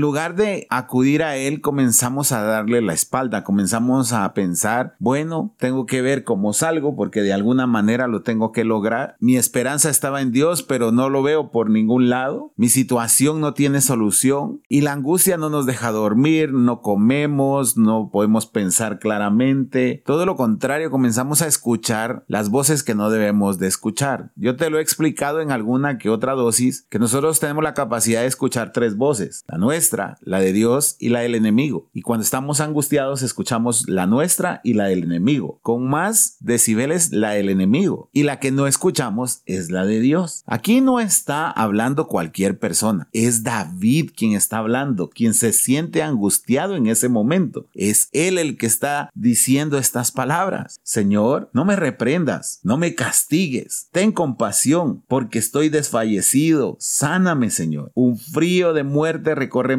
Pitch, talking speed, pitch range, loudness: 130 Hz, 170 wpm, 115-150 Hz, -18 LUFS